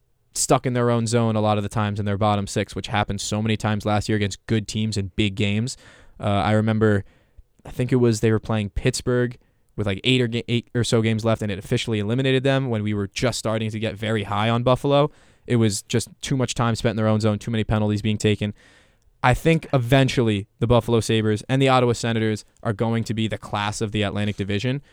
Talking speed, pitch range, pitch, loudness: 240 wpm, 105-120 Hz, 110 Hz, -22 LUFS